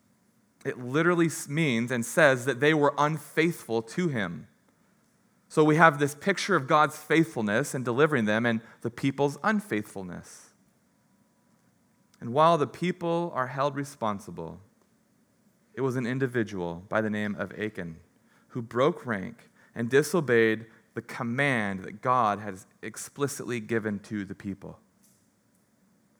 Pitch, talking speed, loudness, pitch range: 130 Hz, 130 wpm, -27 LUFS, 110-155 Hz